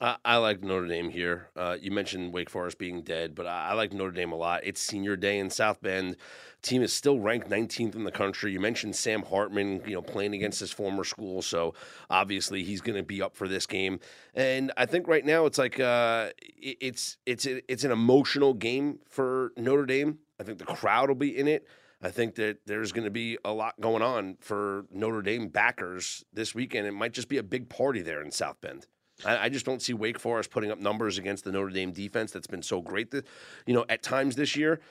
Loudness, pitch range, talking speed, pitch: -29 LUFS, 95-130 Hz, 225 wpm, 110 Hz